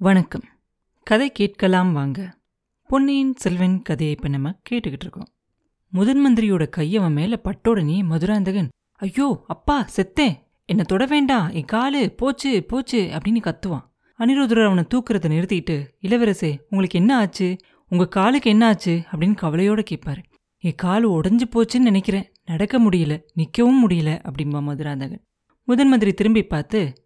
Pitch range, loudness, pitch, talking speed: 170-230 Hz, -20 LUFS, 195 Hz, 125 wpm